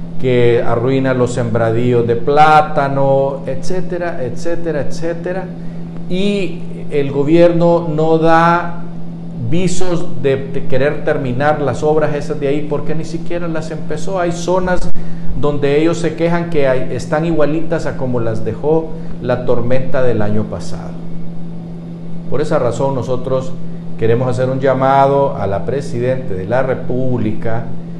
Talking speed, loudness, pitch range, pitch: 135 wpm, -16 LUFS, 130-170 Hz, 155 Hz